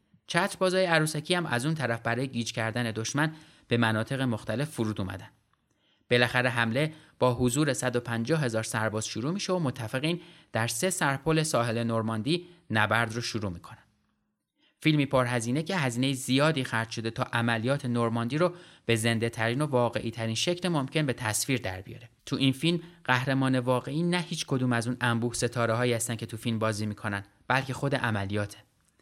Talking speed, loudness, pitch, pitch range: 165 wpm, -28 LUFS, 125 Hz, 115-150 Hz